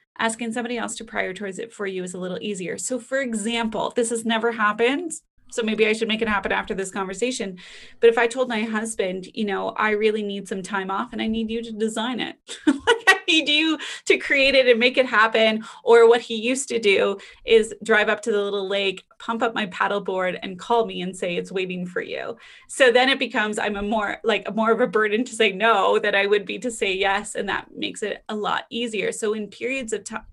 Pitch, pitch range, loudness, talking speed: 225 Hz, 205-245 Hz, -22 LUFS, 240 wpm